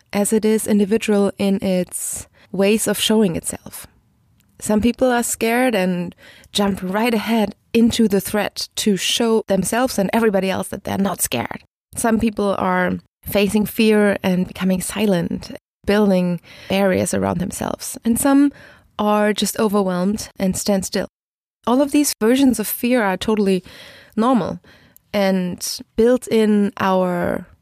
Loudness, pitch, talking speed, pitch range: -19 LUFS, 210 Hz, 140 wpm, 195-230 Hz